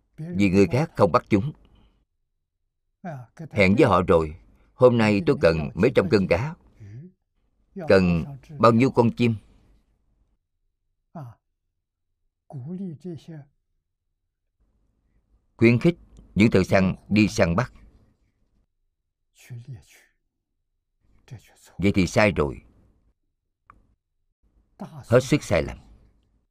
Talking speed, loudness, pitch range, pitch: 90 wpm, -21 LUFS, 85-125 Hz, 100 Hz